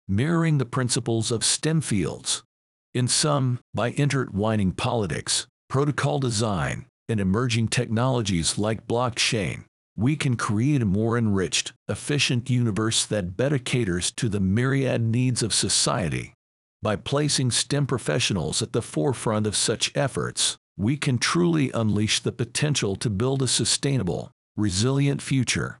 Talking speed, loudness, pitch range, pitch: 135 wpm, -24 LUFS, 105-135 Hz, 120 Hz